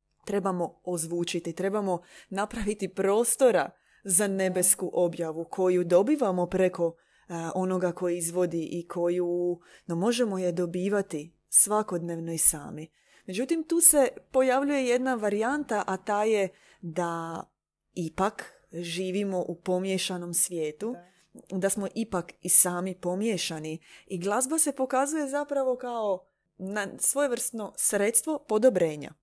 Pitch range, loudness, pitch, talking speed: 175-225 Hz, -26 LUFS, 190 Hz, 110 wpm